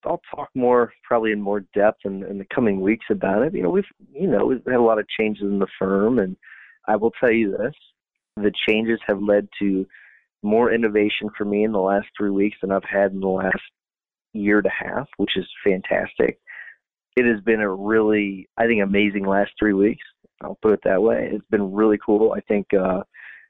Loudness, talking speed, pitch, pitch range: -21 LUFS, 215 wpm, 105 Hz, 100-110 Hz